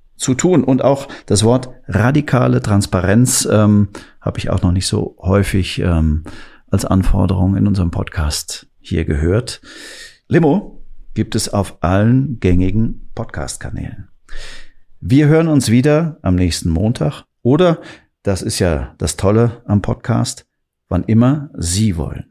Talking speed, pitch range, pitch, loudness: 135 wpm, 95-125 Hz, 105 Hz, -16 LUFS